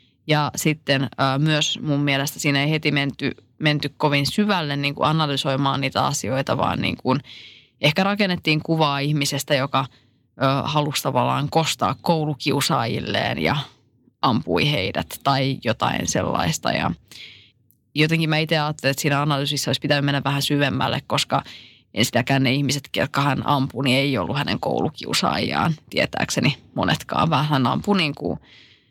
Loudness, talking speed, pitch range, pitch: -21 LUFS, 140 wpm, 135-150 Hz, 140 Hz